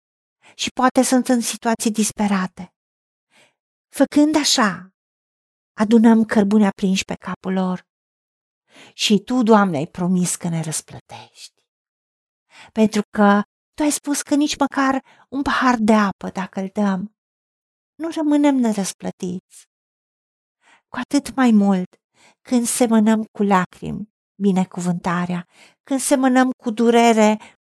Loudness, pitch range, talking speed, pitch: -18 LUFS, 190-255 Hz, 115 wpm, 220 Hz